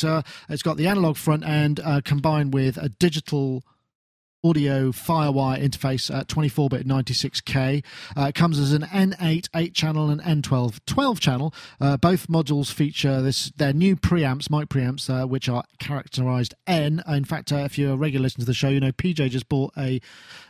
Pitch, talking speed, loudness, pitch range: 145 Hz, 180 wpm, -23 LUFS, 135-155 Hz